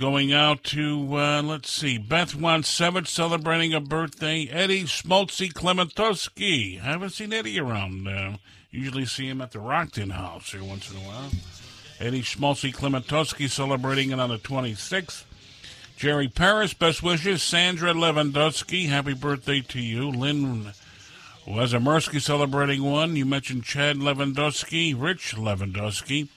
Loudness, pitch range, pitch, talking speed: -24 LUFS, 125-160 Hz, 145 Hz, 140 wpm